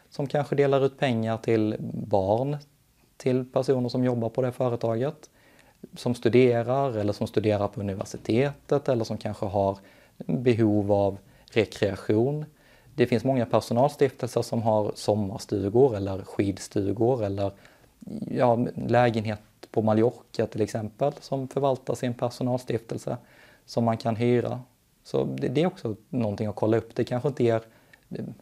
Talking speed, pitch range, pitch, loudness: 135 wpm, 110-130 Hz, 120 Hz, -26 LUFS